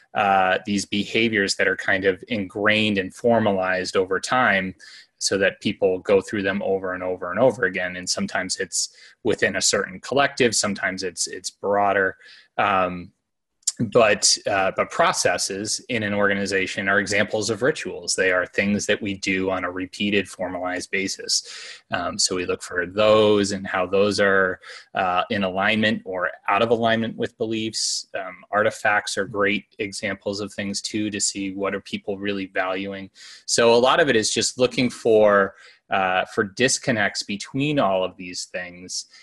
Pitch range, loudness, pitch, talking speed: 95-110 Hz, -22 LUFS, 100 Hz, 165 wpm